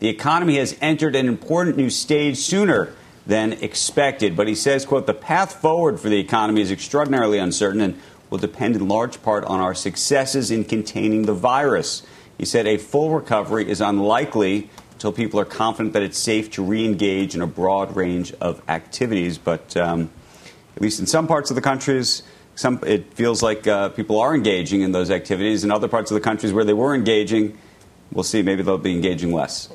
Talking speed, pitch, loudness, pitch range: 195 wpm, 105 Hz, -20 LUFS, 100-125 Hz